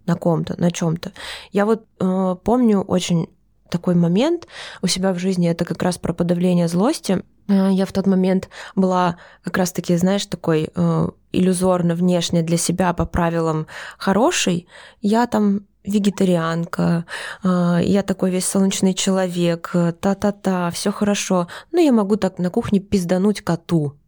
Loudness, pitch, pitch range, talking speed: -19 LUFS, 185 Hz, 175-195 Hz, 150 wpm